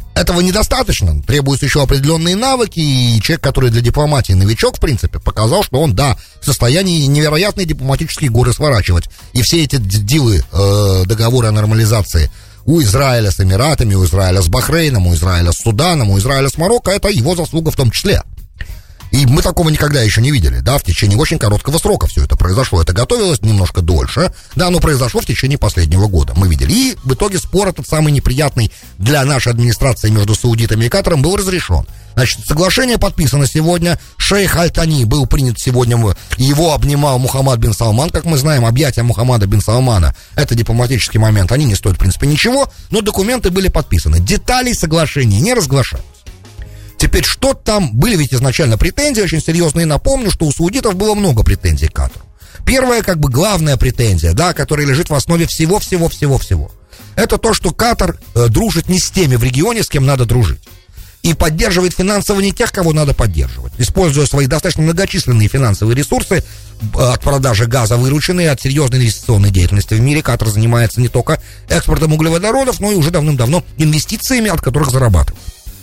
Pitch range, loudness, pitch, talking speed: 105-165 Hz, -13 LUFS, 130 Hz, 170 wpm